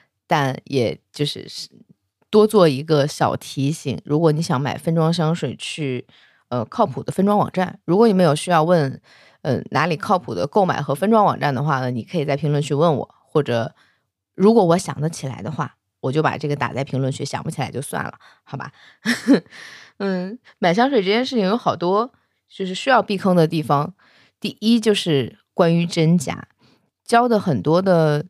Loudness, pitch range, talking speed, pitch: -20 LUFS, 140-185 Hz, 270 characters per minute, 160 Hz